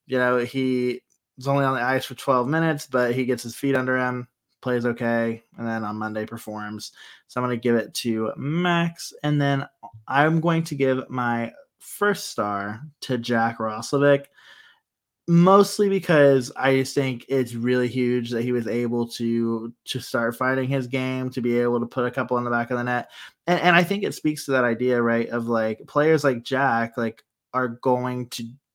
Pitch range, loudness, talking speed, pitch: 120-140 Hz, -23 LUFS, 195 wpm, 125 Hz